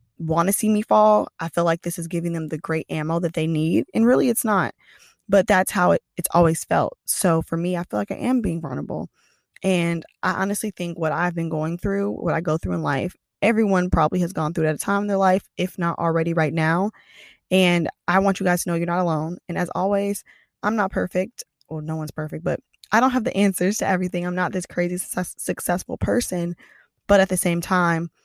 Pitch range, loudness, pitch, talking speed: 165-195 Hz, -22 LUFS, 175 Hz, 240 wpm